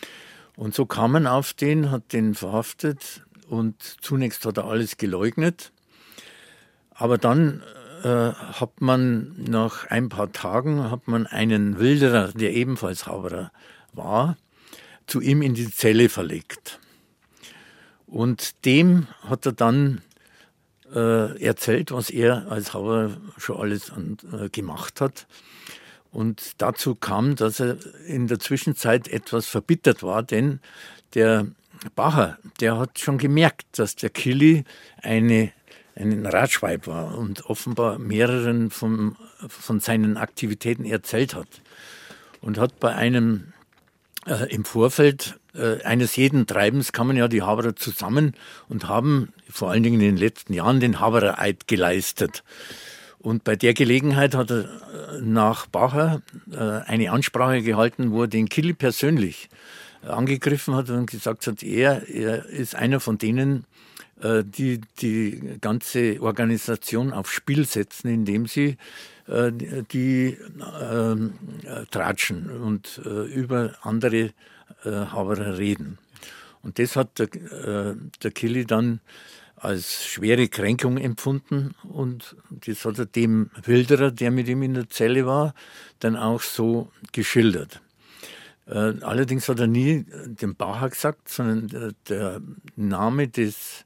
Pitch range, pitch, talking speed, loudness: 110-130 Hz, 115 Hz, 130 wpm, -23 LUFS